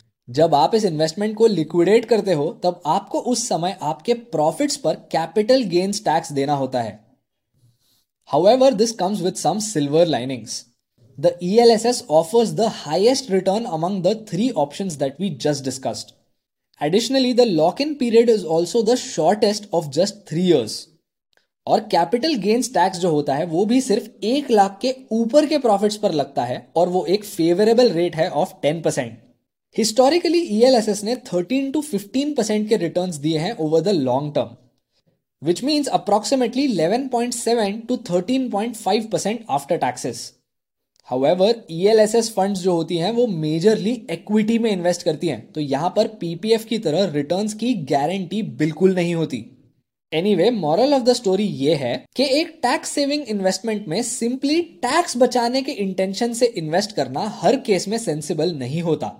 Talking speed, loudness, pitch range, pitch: 160 wpm, -20 LUFS, 160-235 Hz, 195 Hz